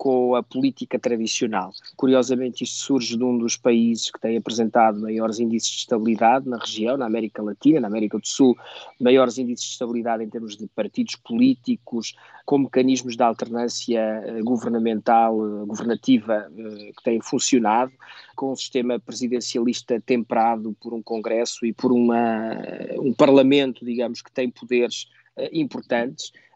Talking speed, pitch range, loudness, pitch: 140 wpm, 115-130 Hz, -22 LUFS, 120 Hz